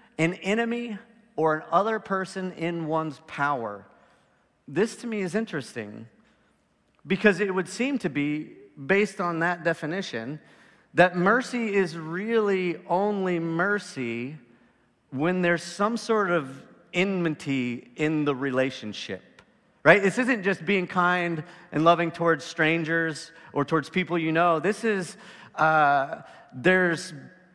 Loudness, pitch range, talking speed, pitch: -25 LUFS, 155-195 Hz, 125 wpm, 175 Hz